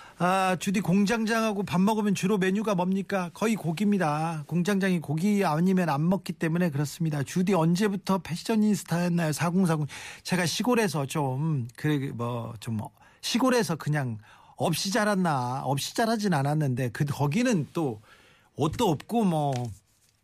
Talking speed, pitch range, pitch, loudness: 300 characters per minute, 145-200 Hz, 175 Hz, -27 LUFS